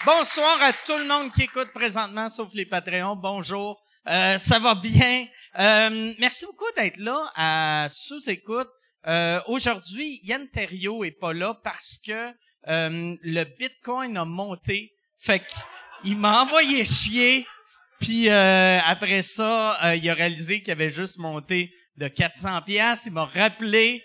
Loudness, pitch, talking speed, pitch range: -22 LUFS, 210 Hz, 145 wpm, 180-245 Hz